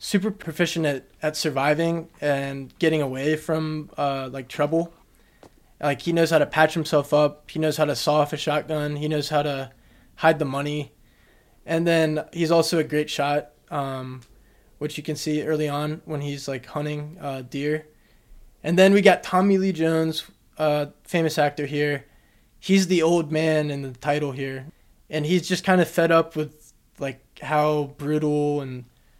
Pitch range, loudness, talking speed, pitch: 140-160 Hz, -23 LUFS, 175 wpm, 150 Hz